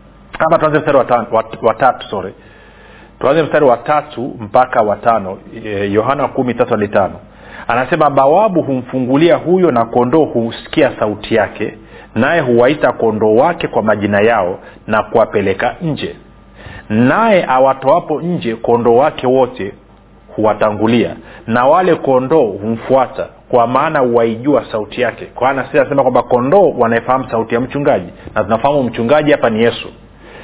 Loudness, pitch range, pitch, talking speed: -13 LUFS, 115-140 Hz, 125 Hz, 120 wpm